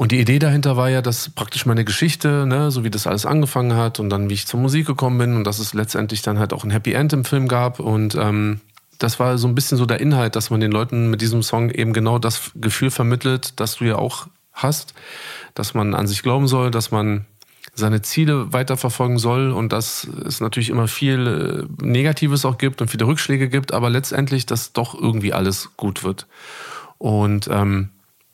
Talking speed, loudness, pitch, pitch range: 210 wpm, -19 LUFS, 120 Hz, 110-135 Hz